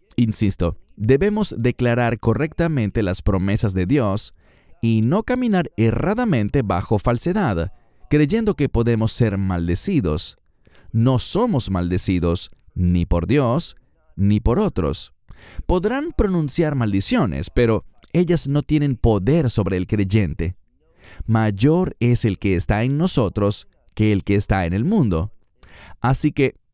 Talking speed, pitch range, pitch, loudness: 125 wpm, 95-145 Hz, 115 Hz, -20 LUFS